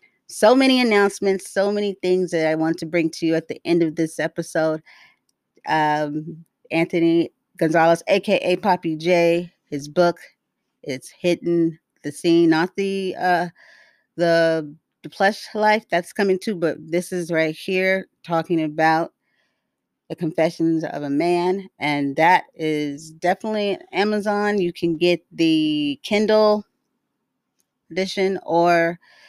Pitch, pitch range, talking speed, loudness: 170 Hz, 160-195 Hz, 130 wpm, -20 LUFS